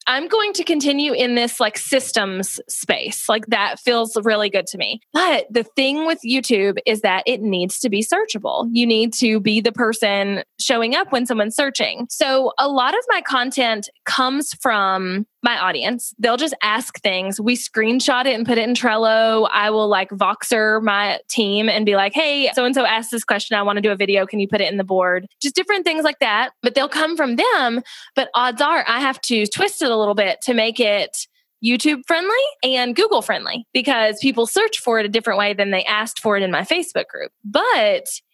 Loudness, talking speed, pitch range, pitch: -18 LUFS, 215 wpm, 215-270 Hz, 235 Hz